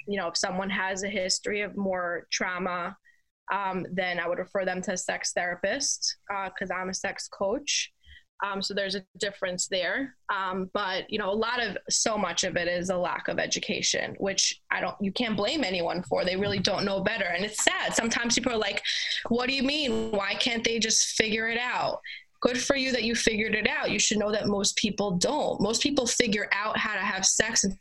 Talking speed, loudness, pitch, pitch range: 220 wpm, -27 LUFS, 205 Hz, 190-230 Hz